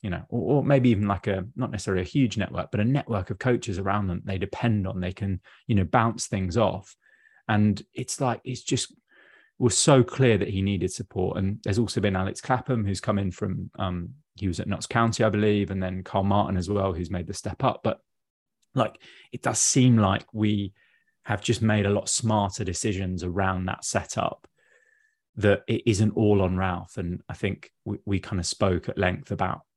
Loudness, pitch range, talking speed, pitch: -26 LUFS, 95-115 Hz, 215 wpm, 100 Hz